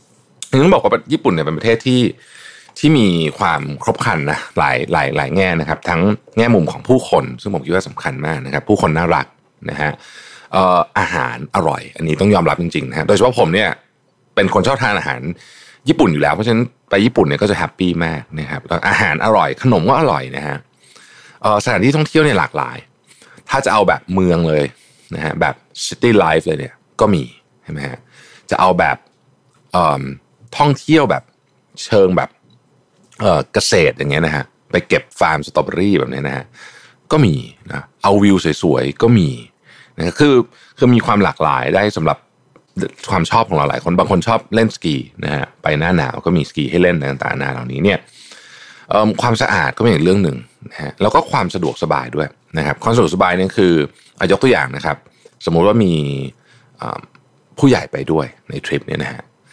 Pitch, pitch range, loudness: 90 Hz, 75-115 Hz, -15 LUFS